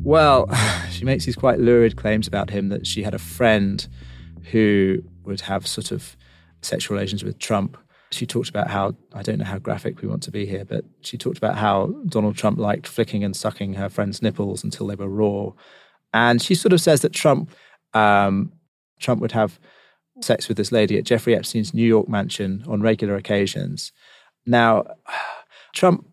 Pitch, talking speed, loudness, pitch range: 105 Hz, 180 wpm, -21 LUFS, 95-115 Hz